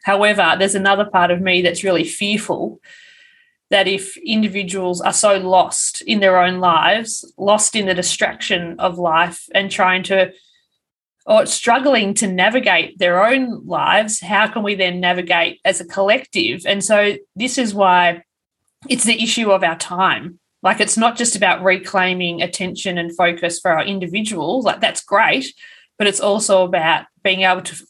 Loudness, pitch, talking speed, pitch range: -16 LUFS, 195 Hz, 165 wpm, 180-215 Hz